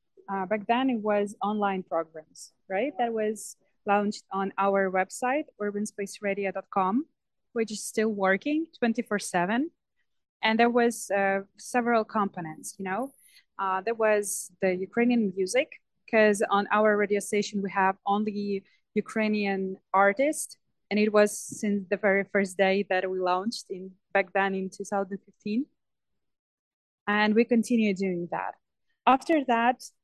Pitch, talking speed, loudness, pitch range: 205 Hz, 140 wpm, -27 LUFS, 195-230 Hz